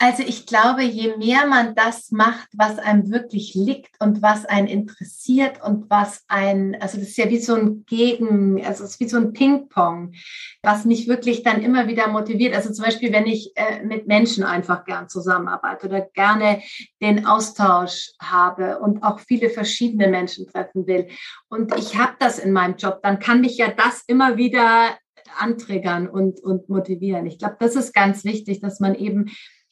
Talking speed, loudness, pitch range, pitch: 185 wpm, -19 LUFS, 195-230 Hz, 210 Hz